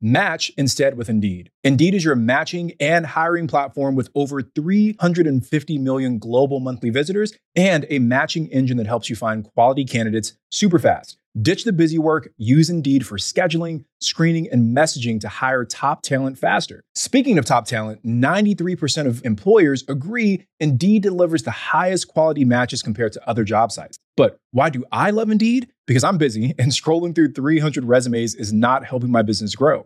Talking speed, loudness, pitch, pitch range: 170 wpm, -19 LUFS, 140 Hz, 125-165 Hz